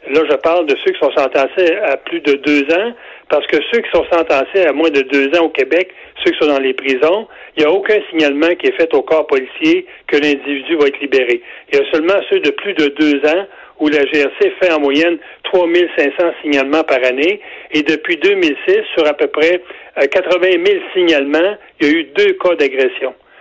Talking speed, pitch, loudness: 220 wpm, 190 Hz, -14 LUFS